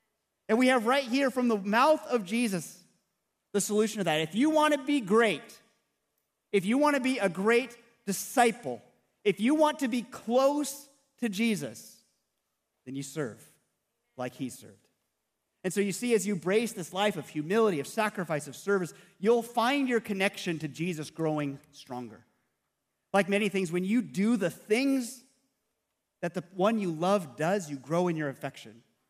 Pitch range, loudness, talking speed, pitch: 160-240 Hz, -29 LUFS, 175 wpm, 200 Hz